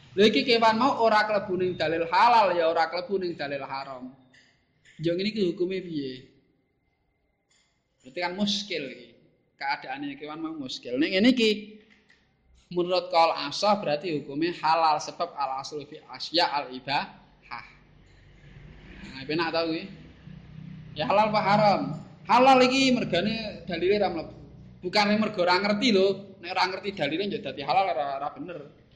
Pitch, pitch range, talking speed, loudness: 175 Hz, 155-210 Hz, 145 wpm, -25 LUFS